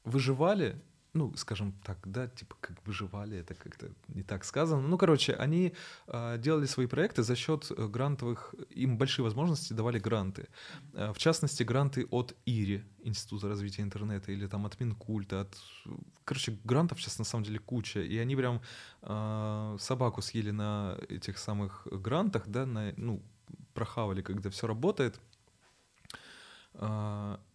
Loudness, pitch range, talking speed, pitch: -34 LUFS, 105-135 Hz, 145 wpm, 115 Hz